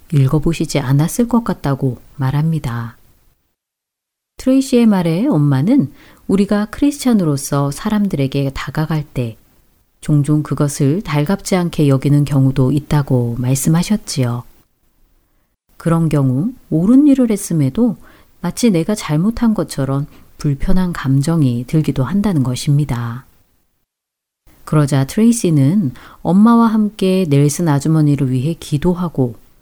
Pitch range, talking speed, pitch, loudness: 135-190 Hz, 270 characters per minute, 150 Hz, -15 LUFS